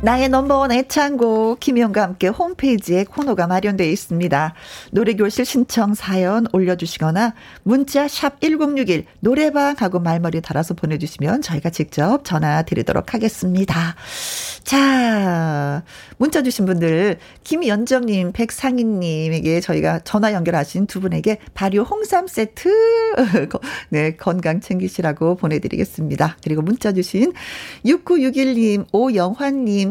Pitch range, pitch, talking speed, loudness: 170-255 Hz, 205 Hz, 290 characters per minute, -18 LUFS